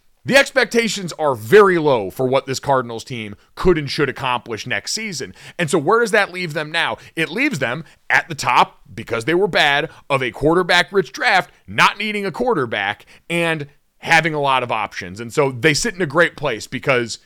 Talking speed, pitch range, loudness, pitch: 200 wpm, 130-185 Hz, -18 LUFS, 160 Hz